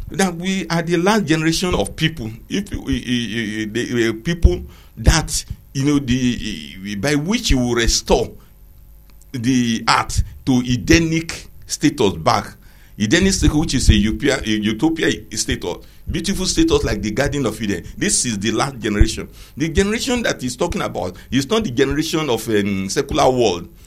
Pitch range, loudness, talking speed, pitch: 110-165 Hz, -19 LUFS, 170 wpm, 130 Hz